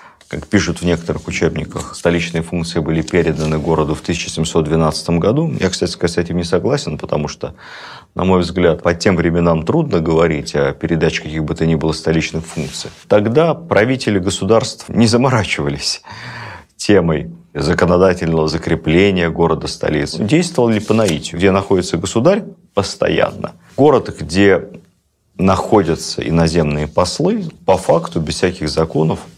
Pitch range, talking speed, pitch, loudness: 80-100 Hz, 135 wpm, 85 Hz, -16 LUFS